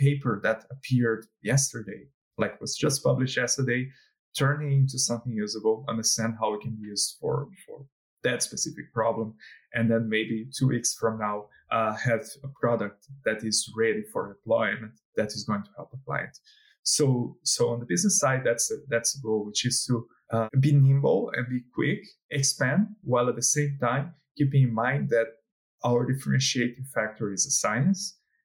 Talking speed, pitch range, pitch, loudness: 175 wpm, 115-140 Hz, 125 Hz, -27 LUFS